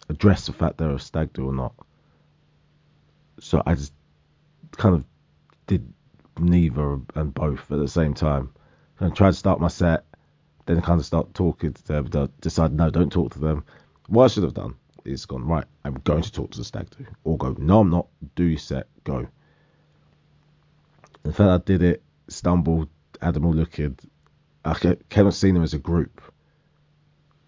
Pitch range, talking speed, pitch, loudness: 75-95 Hz, 190 wpm, 85 Hz, -23 LUFS